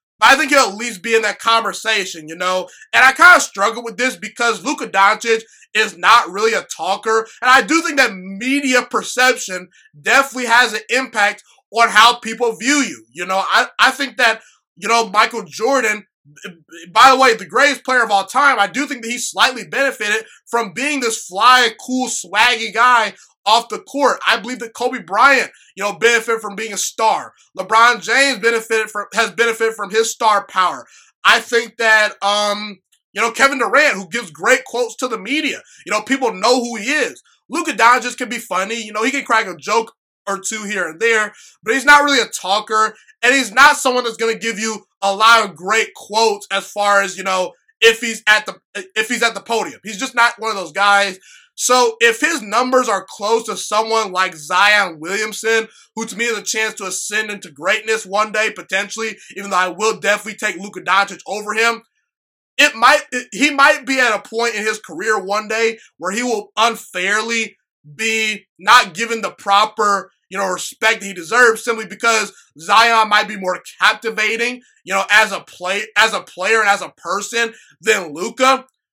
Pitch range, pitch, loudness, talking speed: 205-245 Hz, 225 Hz, -15 LUFS, 200 wpm